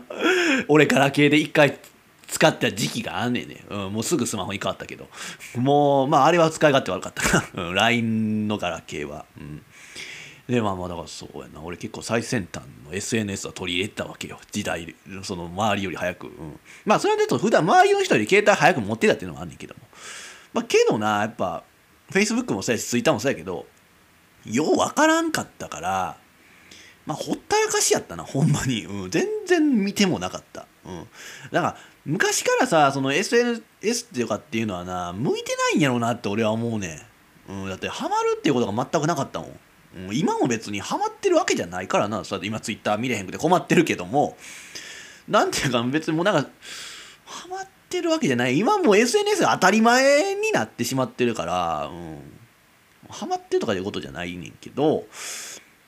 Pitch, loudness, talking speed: 130 Hz, -22 LUFS, 425 characters per minute